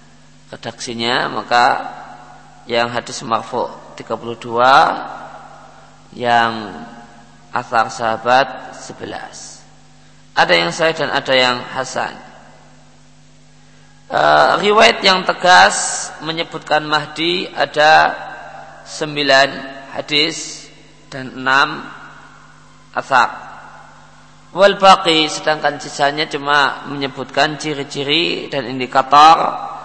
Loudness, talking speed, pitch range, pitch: -15 LUFS, 75 wpm, 120-150 Hz, 135 Hz